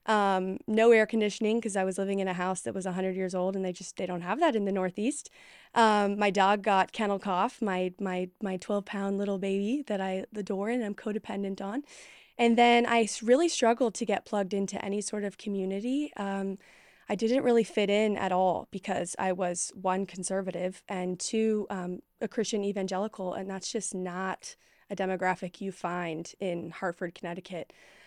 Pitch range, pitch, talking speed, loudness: 185-215 Hz, 195 Hz, 190 wpm, -30 LUFS